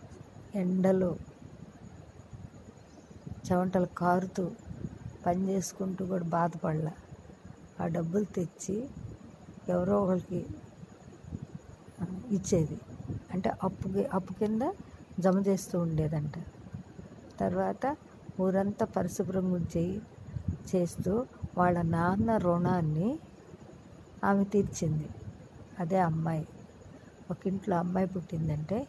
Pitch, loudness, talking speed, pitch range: 185 Hz, -32 LUFS, 75 wpm, 170-195 Hz